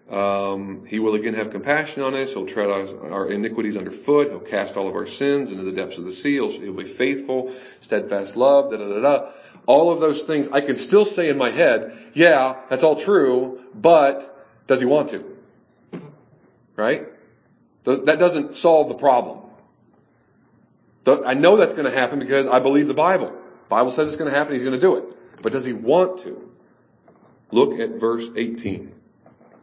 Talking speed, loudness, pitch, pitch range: 180 wpm, -20 LUFS, 130 Hz, 110-145 Hz